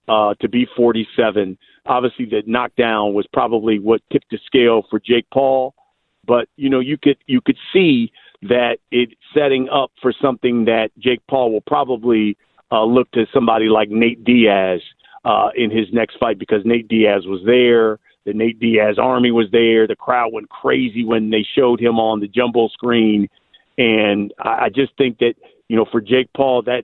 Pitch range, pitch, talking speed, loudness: 110-125 Hz, 115 Hz, 185 wpm, -16 LUFS